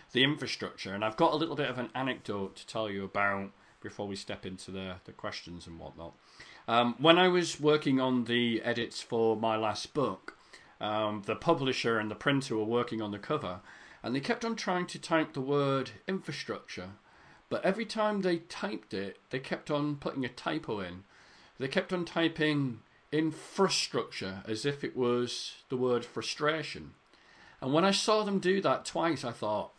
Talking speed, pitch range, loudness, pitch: 185 wpm, 110-160 Hz, -32 LUFS, 130 Hz